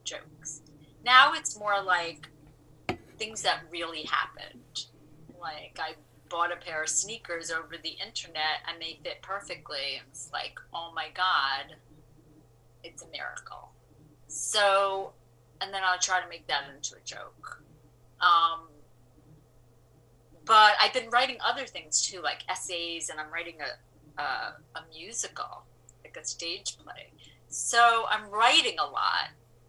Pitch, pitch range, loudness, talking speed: 165 Hz, 145-195 Hz, -28 LUFS, 135 wpm